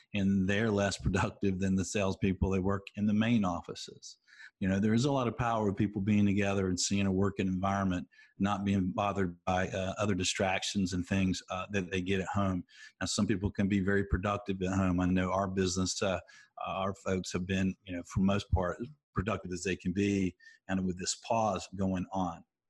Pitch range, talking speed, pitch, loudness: 95-100 Hz, 210 wpm, 95 Hz, -32 LUFS